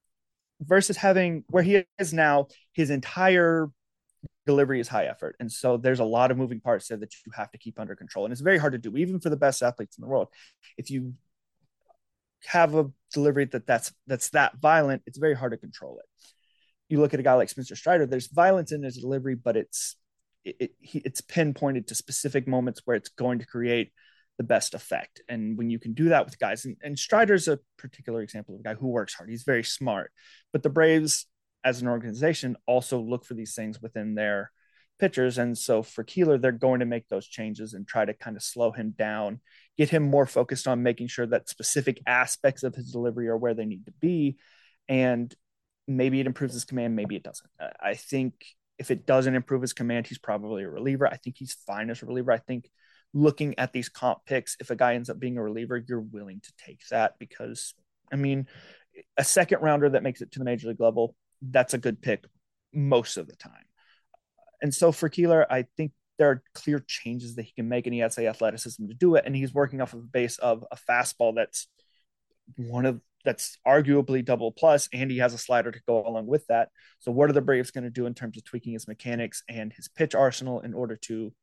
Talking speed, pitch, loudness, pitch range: 220 wpm, 125 Hz, -26 LUFS, 115-145 Hz